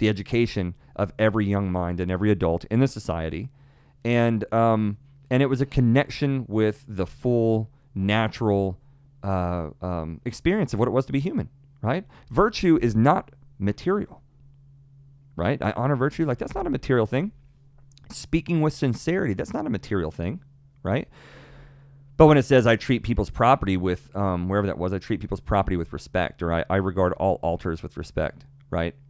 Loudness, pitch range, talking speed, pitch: -24 LUFS, 95-140 Hz, 175 wpm, 115 Hz